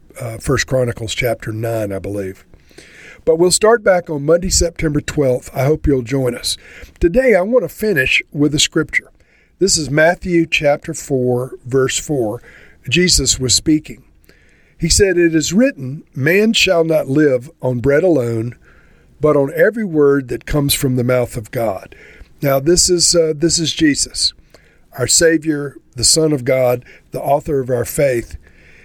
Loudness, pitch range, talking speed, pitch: -15 LUFS, 125-165 Hz, 165 wpm, 145 Hz